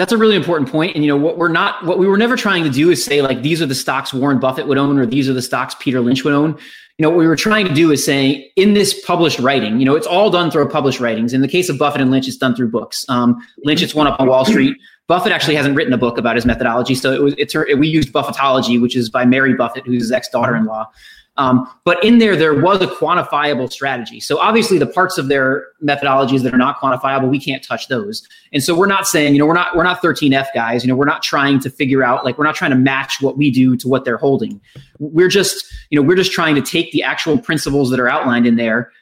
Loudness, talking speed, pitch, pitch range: -14 LUFS, 280 wpm, 140 Hz, 130-165 Hz